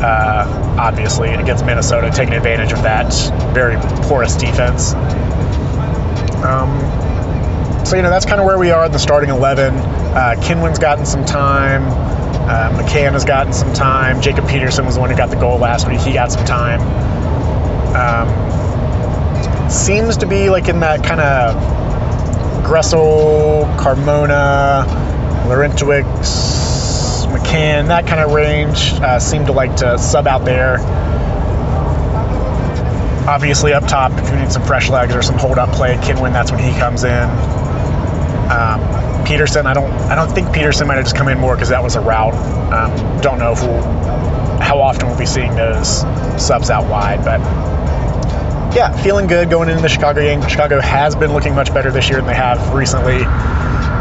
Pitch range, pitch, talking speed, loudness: 105-140 Hz, 125 Hz, 165 wpm, -14 LUFS